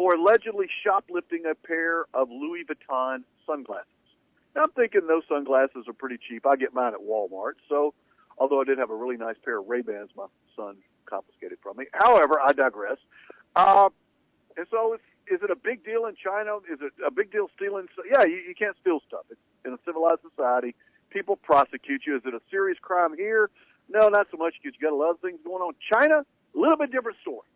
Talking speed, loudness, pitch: 210 wpm, -25 LUFS, 175 Hz